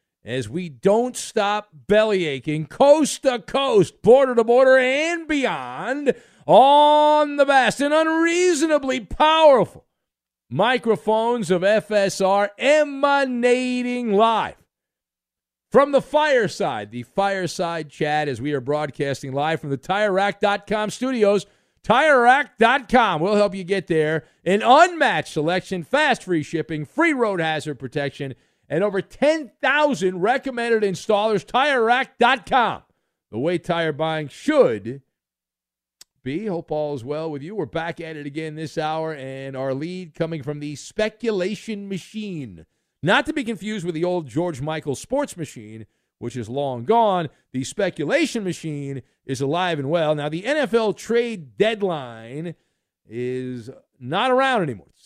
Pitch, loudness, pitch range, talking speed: 190 Hz, -20 LUFS, 150-240 Hz, 130 wpm